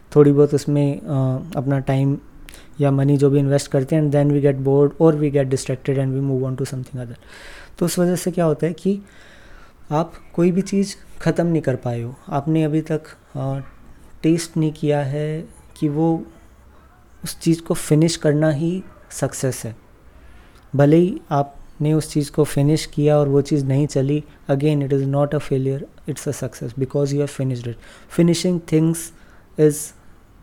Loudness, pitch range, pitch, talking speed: -20 LUFS, 135-155 Hz, 145 Hz, 185 wpm